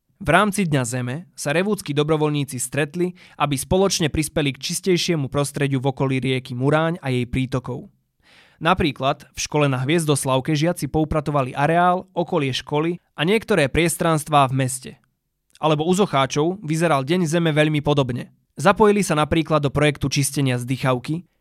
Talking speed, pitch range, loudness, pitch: 145 wpm, 140-170 Hz, -21 LUFS, 150 Hz